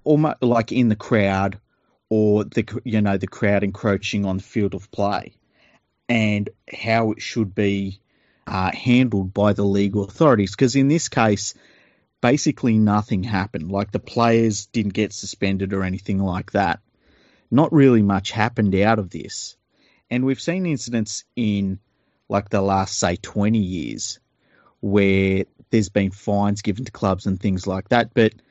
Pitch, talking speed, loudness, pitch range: 105 Hz, 160 wpm, -21 LUFS, 100-115 Hz